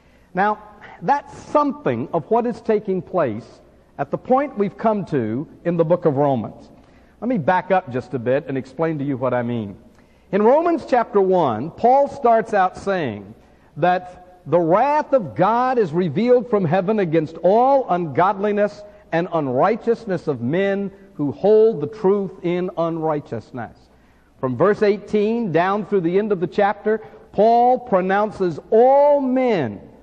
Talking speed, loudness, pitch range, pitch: 155 wpm, -19 LUFS, 165-220 Hz, 190 Hz